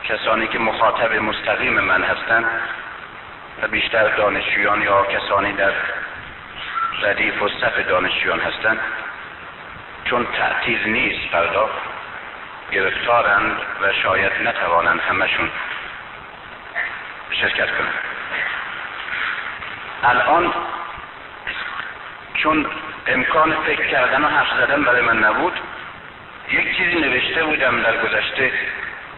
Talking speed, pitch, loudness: 95 wpm, 115 Hz, -18 LUFS